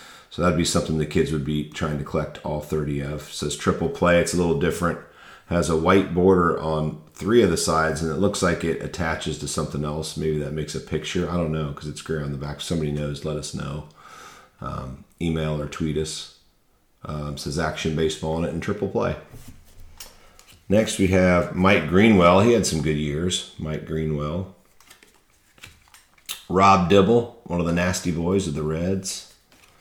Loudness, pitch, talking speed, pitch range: -23 LUFS, 80 Hz, 190 wpm, 75-90 Hz